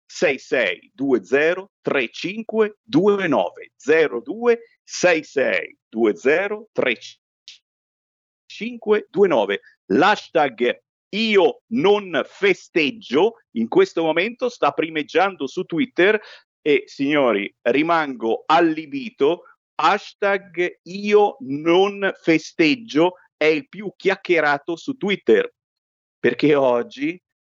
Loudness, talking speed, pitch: -20 LUFS, 70 wpm, 210 Hz